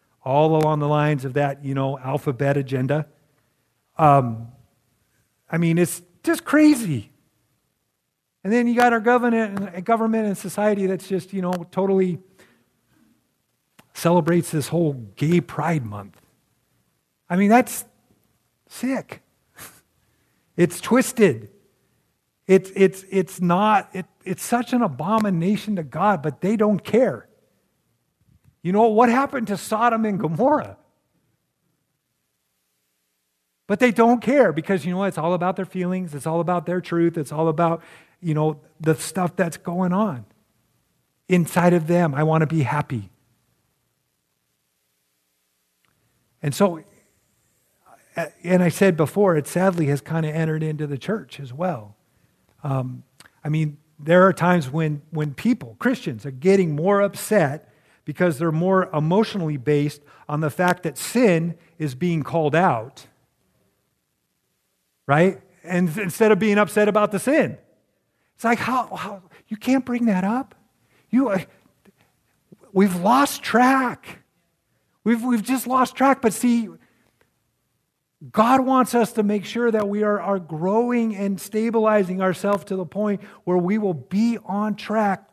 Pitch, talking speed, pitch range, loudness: 180 Hz, 140 wpm, 150-210 Hz, -21 LUFS